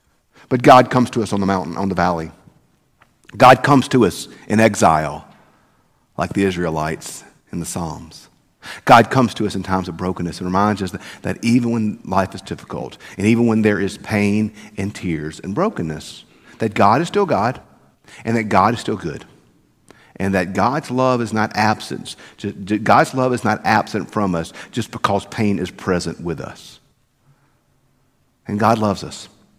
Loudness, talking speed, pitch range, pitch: -18 LUFS, 180 wpm, 95-120 Hz, 105 Hz